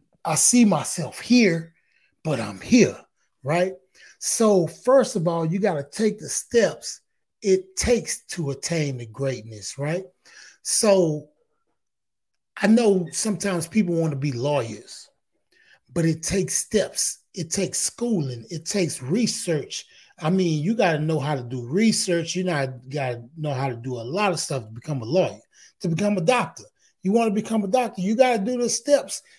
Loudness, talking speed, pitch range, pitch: -23 LUFS, 175 wpm, 150-215 Hz, 180 Hz